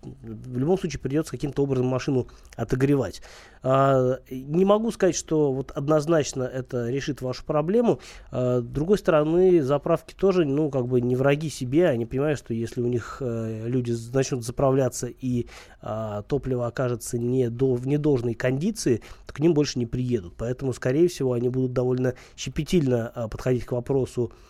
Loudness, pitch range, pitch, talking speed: -25 LUFS, 120-150 Hz, 130 Hz, 145 wpm